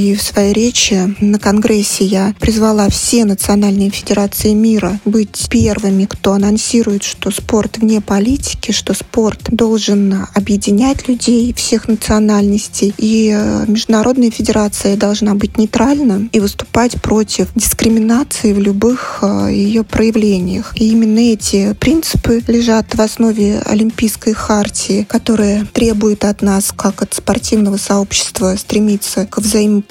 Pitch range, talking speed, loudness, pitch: 205-225 Hz, 120 wpm, -12 LUFS, 215 Hz